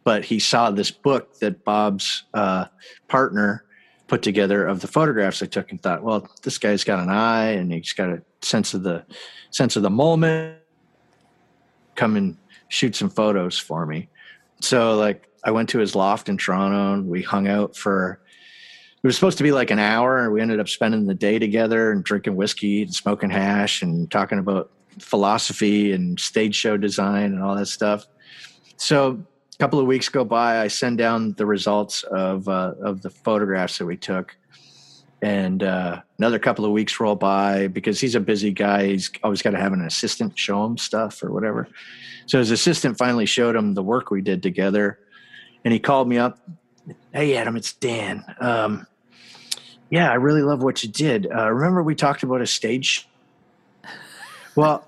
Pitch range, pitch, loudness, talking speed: 100-125 Hz, 105 Hz, -21 LUFS, 185 wpm